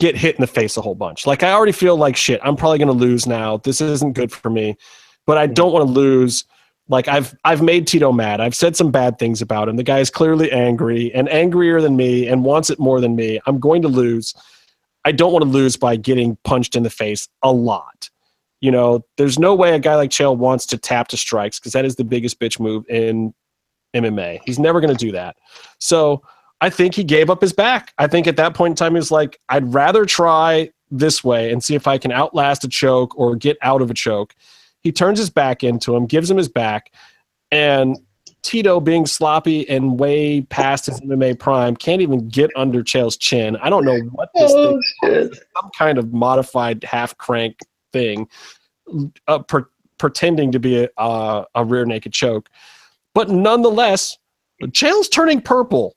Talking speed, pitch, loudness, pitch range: 210 wpm, 135 Hz, -16 LUFS, 120-160 Hz